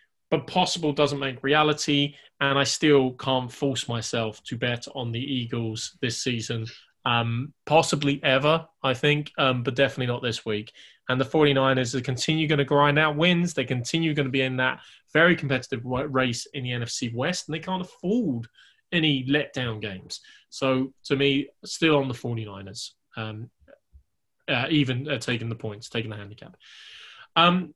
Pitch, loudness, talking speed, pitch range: 135 Hz, -25 LUFS, 170 wpm, 120-150 Hz